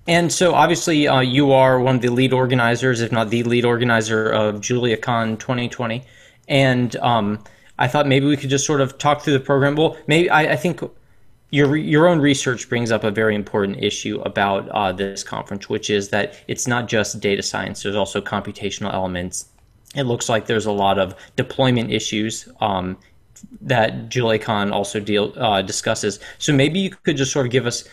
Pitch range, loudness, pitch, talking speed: 105-135 Hz, -19 LUFS, 120 Hz, 190 wpm